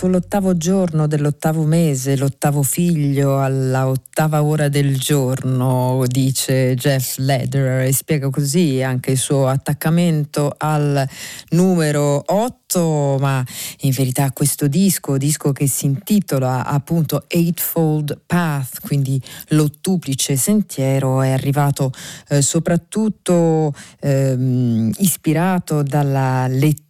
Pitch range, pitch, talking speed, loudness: 135-160 Hz, 145 Hz, 105 wpm, -17 LUFS